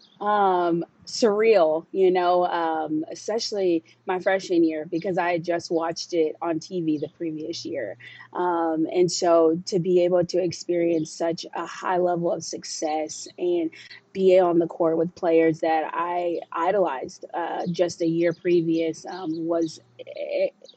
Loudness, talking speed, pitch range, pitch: -24 LUFS, 150 wpm, 165-185 Hz, 170 Hz